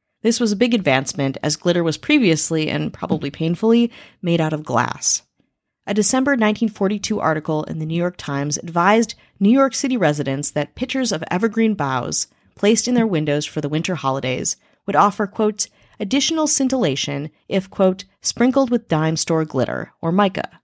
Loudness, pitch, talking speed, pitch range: -19 LUFS, 195 Hz, 165 wpm, 155-230 Hz